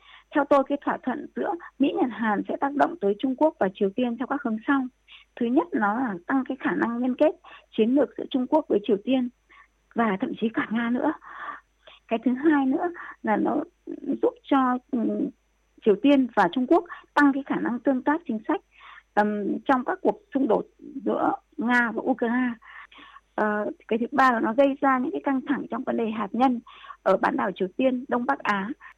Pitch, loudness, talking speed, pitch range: 275 Hz, -25 LUFS, 205 wpm, 240-305 Hz